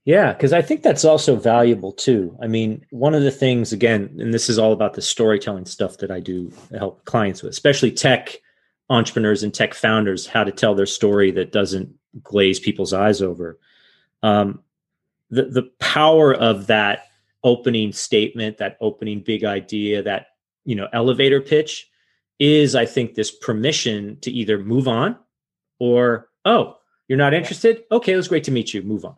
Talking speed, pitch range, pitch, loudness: 175 wpm, 105-135 Hz, 115 Hz, -19 LUFS